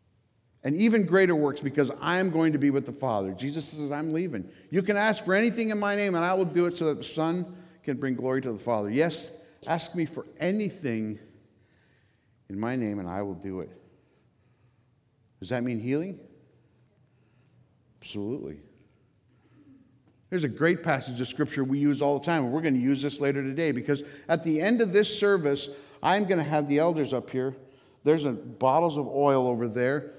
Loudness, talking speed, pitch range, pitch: -27 LUFS, 195 wpm, 125-165 Hz, 140 Hz